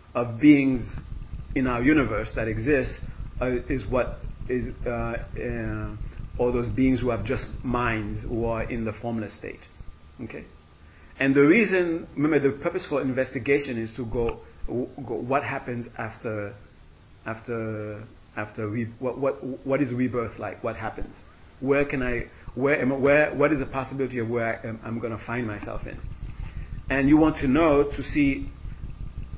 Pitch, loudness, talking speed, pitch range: 120 Hz, -26 LUFS, 165 wpm, 115-135 Hz